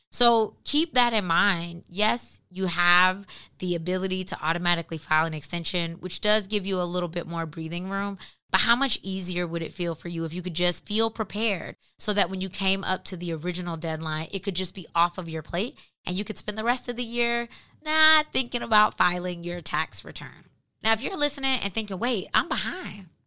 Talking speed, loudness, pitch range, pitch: 215 wpm, -25 LUFS, 170-215 Hz, 185 Hz